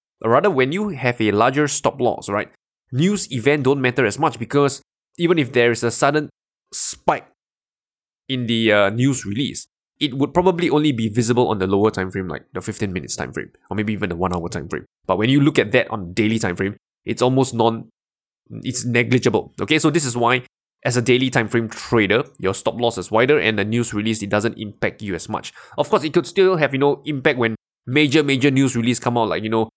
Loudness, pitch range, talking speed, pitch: -19 LUFS, 110-140 Hz, 230 wpm, 120 Hz